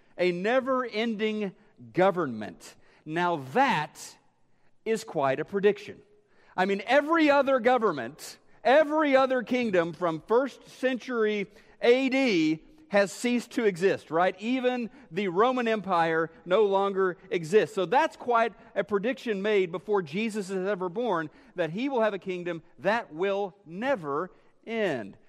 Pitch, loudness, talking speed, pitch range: 210 Hz, -27 LUFS, 130 wpm, 185-250 Hz